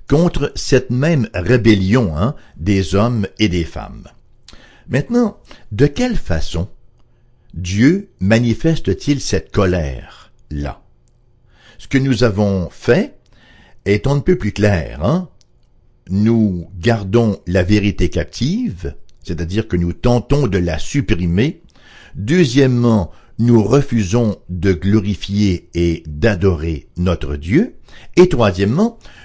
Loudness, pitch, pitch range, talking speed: -16 LUFS, 105 Hz, 90-120 Hz, 105 wpm